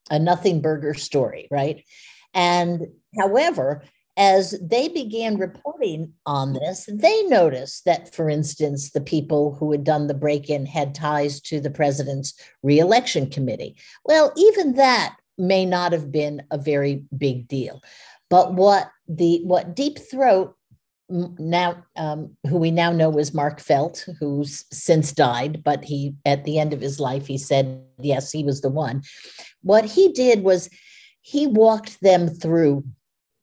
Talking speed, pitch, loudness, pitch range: 150 wpm, 155 Hz, -21 LUFS, 145-185 Hz